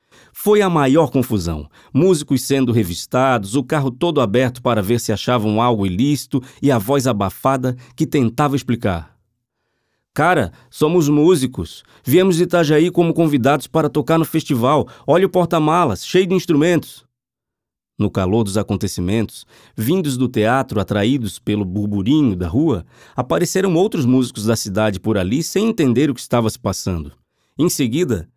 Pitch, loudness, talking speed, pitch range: 130 Hz, -17 LUFS, 150 wpm, 110-155 Hz